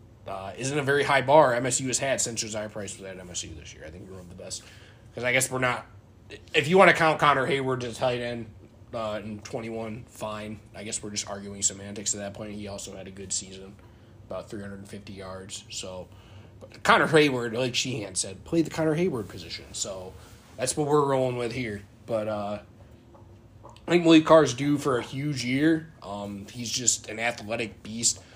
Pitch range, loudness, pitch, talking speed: 100-130 Hz, -25 LUFS, 110 Hz, 215 wpm